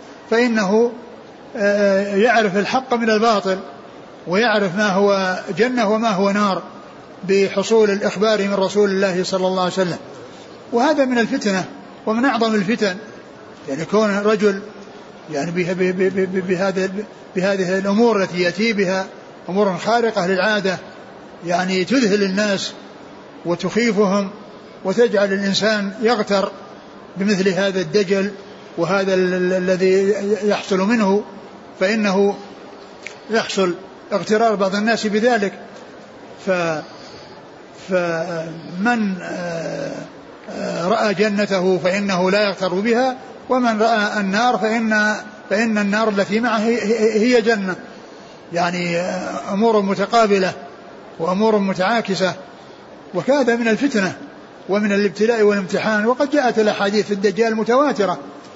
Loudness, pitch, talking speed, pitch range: -18 LUFS, 205 Hz, 100 wpm, 190-220 Hz